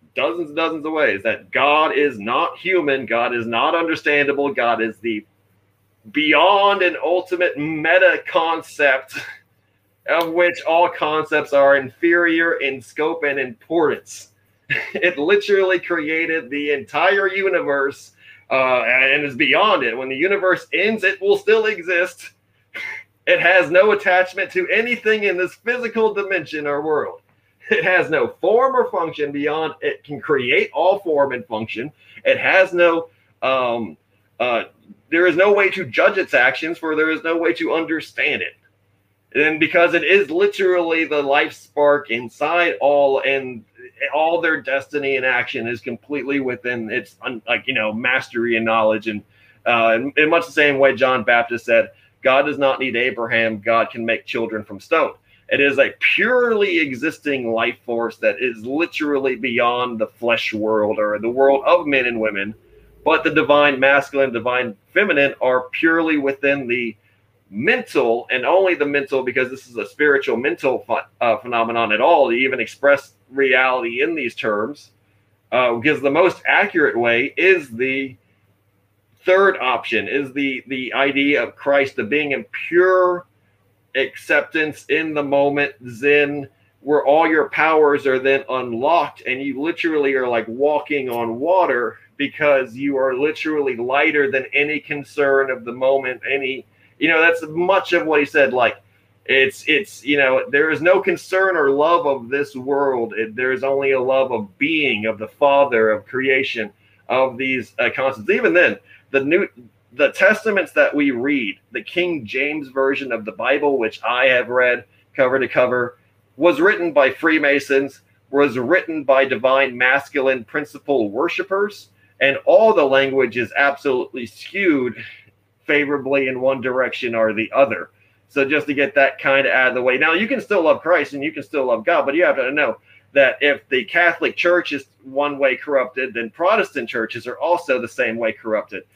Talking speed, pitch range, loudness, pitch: 165 wpm, 125-165 Hz, -18 LUFS, 140 Hz